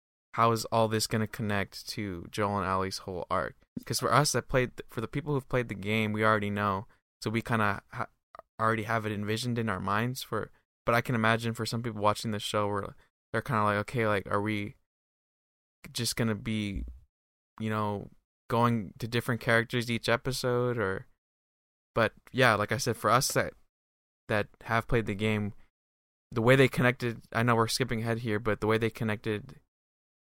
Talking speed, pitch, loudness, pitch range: 195 wpm, 110 Hz, -30 LUFS, 100-115 Hz